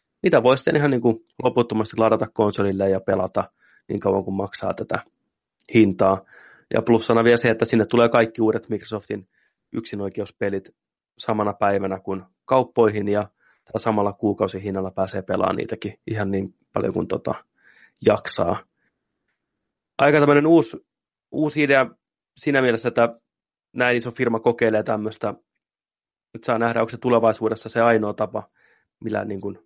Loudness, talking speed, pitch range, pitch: -21 LUFS, 145 wpm, 100-120 Hz, 110 Hz